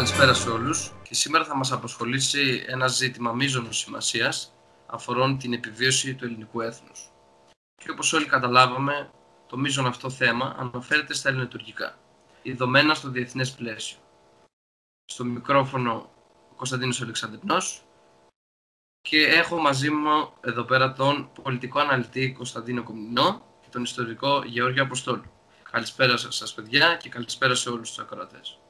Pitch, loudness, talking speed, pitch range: 125 Hz, -24 LUFS, 130 wpm, 110-135 Hz